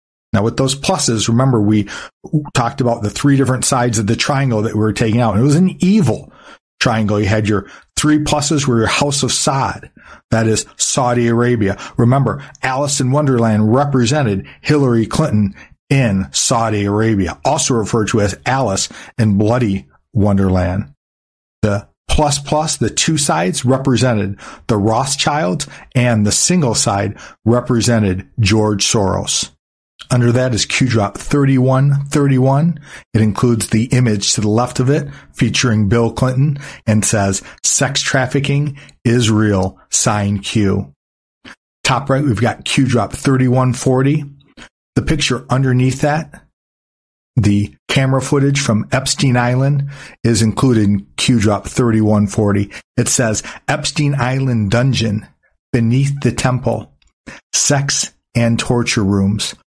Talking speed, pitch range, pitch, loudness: 135 wpm, 105-135 Hz, 120 Hz, -15 LUFS